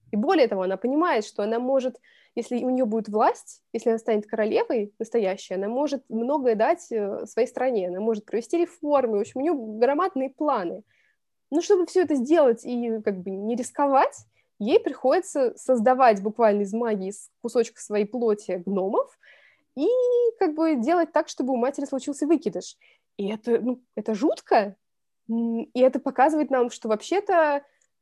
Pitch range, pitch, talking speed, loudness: 220-290 Hz, 245 Hz, 165 wpm, -24 LUFS